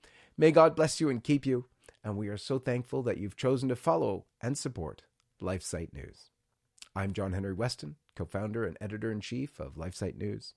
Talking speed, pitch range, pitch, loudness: 175 wpm, 95-130 Hz, 105 Hz, -32 LUFS